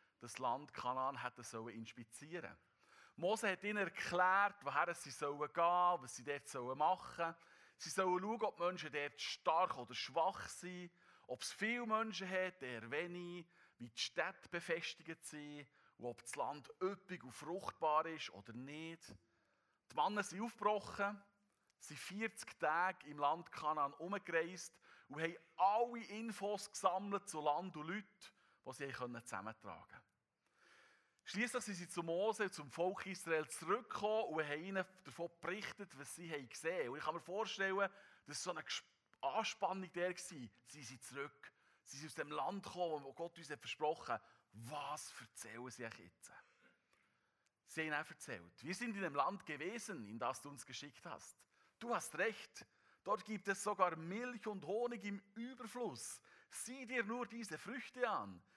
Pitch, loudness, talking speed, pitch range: 170 Hz, -43 LUFS, 160 wpm, 145-200 Hz